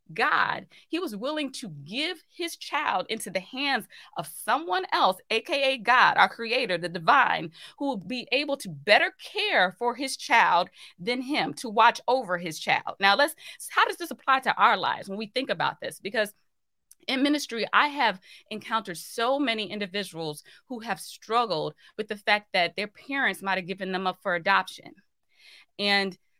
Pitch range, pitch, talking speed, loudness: 195-280 Hz, 235 Hz, 175 wpm, -26 LUFS